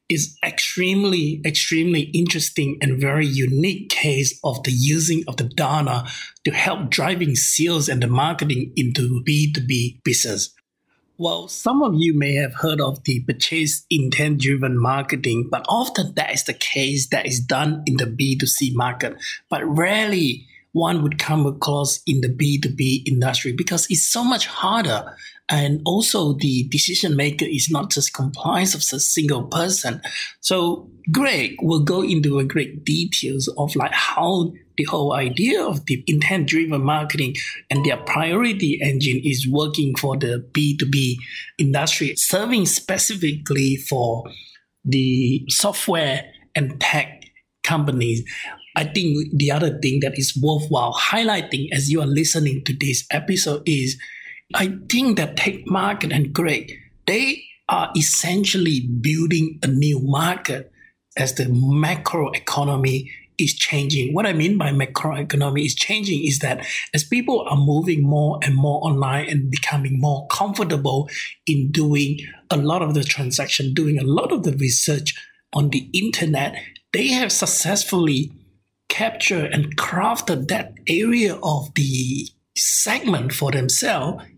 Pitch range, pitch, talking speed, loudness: 135-165 Hz, 150 Hz, 145 wpm, -20 LUFS